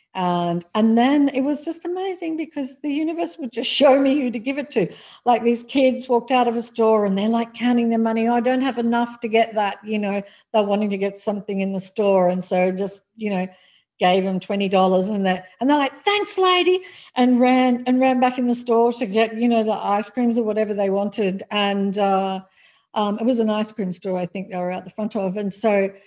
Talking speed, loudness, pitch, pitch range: 240 wpm, -20 LUFS, 225 Hz, 200-255 Hz